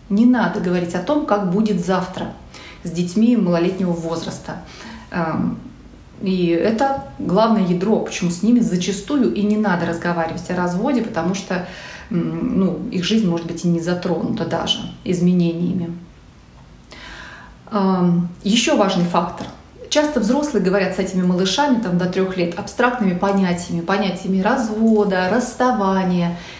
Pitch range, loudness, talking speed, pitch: 175-215 Hz, -19 LUFS, 125 wpm, 190 Hz